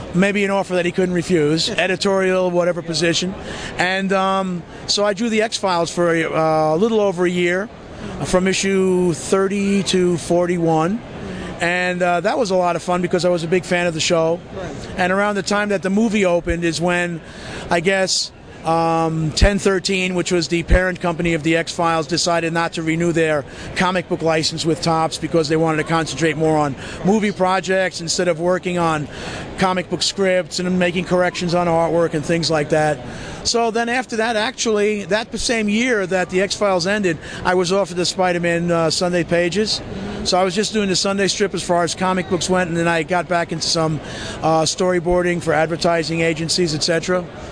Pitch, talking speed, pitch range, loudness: 180 Hz, 195 wpm, 165-190 Hz, -18 LUFS